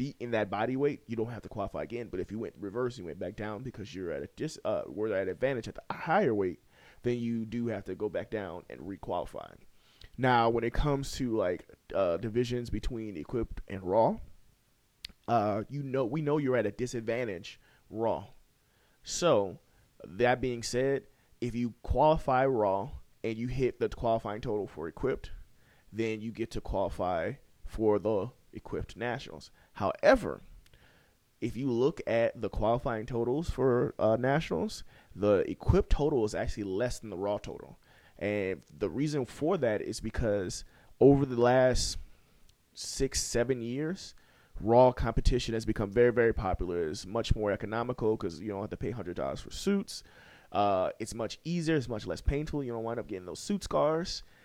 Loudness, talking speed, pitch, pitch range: -31 LUFS, 175 wpm, 115 Hz, 105-130 Hz